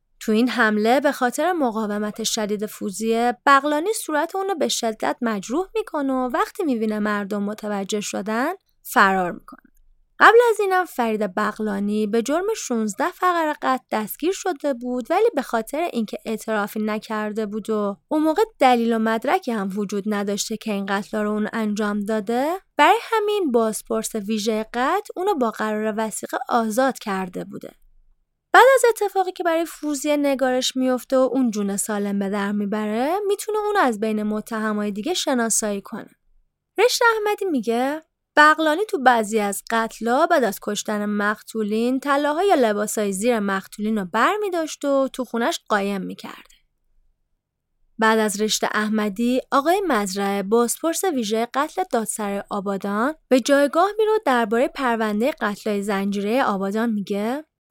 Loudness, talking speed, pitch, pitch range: -21 LUFS, 140 wpm, 235 Hz, 215-300 Hz